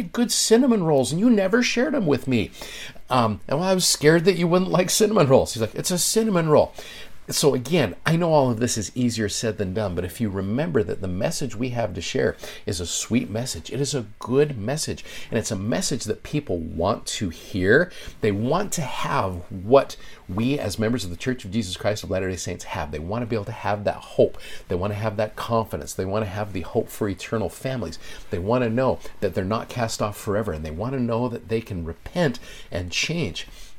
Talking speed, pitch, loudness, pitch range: 235 wpm, 115 Hz, -23 LUFS, 100-140 Hz